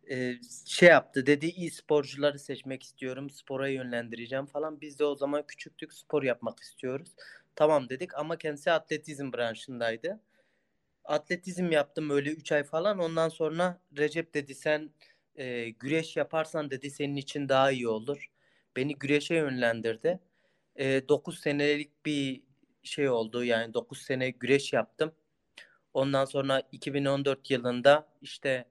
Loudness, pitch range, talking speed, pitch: -30 LUFS, 135-155 Hz, 130 wpm, 145 Hz